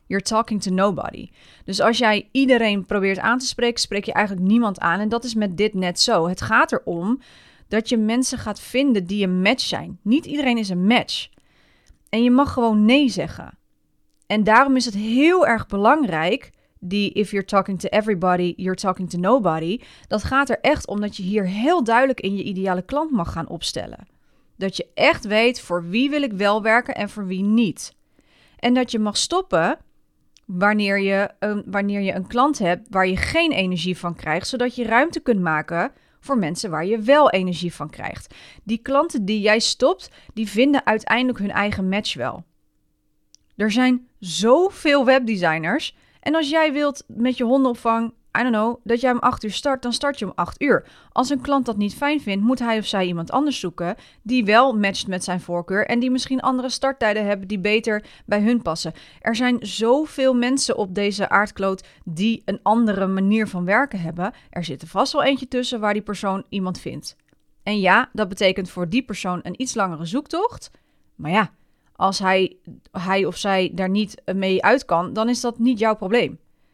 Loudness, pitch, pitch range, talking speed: -20 LUFS, 215 Hz, 190-250 Hz, 195 wpm